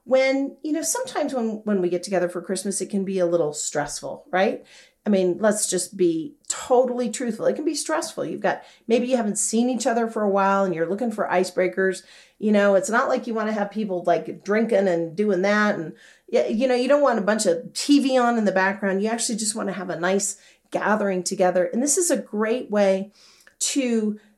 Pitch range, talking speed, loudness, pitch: 190-245 Hz, 225 wpm, -23 LUFS, 210 Hz